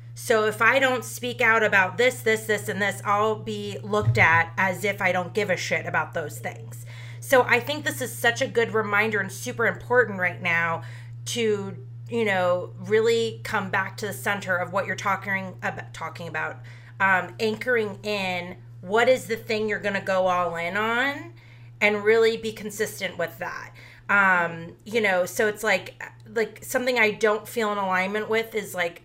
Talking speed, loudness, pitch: 190 wpm, -24 LUFS, 195 Hz